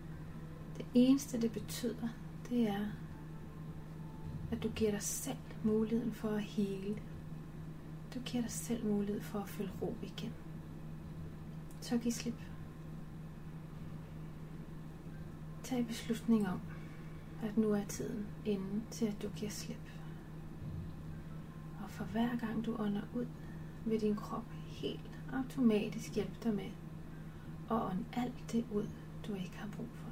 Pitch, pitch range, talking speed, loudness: 210 Hz, 175-225 Hz, 130 wpm, -40 LUFS